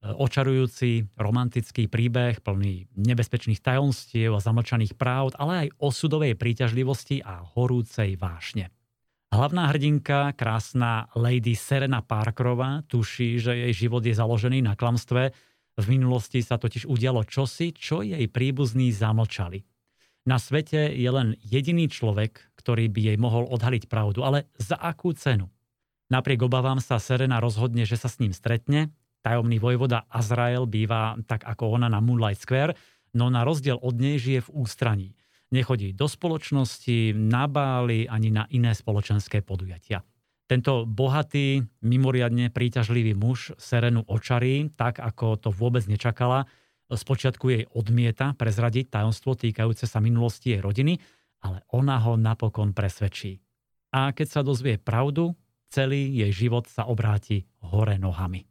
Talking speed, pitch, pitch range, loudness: 135 wpm, 120 Hz, 110-130 Hz, -25 LUFS